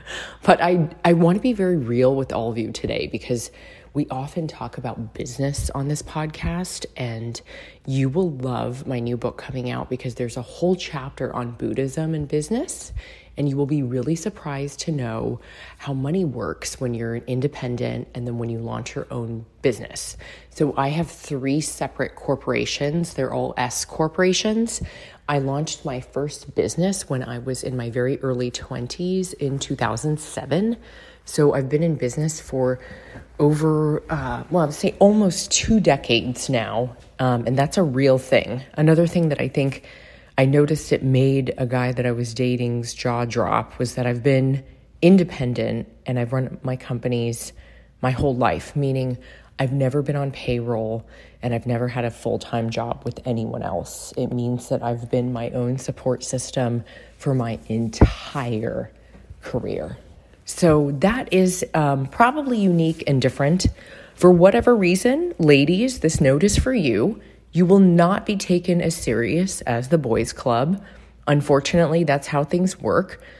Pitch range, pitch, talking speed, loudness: 125-165 Hz, 135 Hz, 165 wpm, -22 LUFS